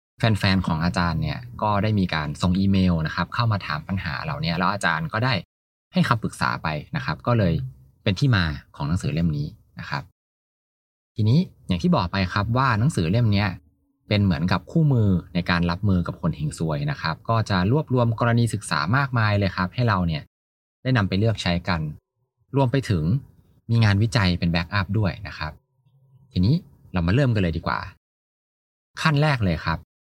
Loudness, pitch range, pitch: -23 LUFS, 85-130 Hz, 100 Hz